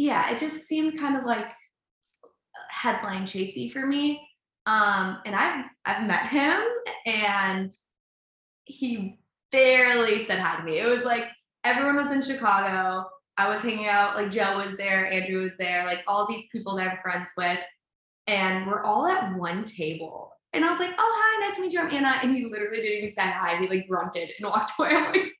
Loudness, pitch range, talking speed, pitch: -25 LUFS, 190-275 Hz, 195 wpm, 210 Hz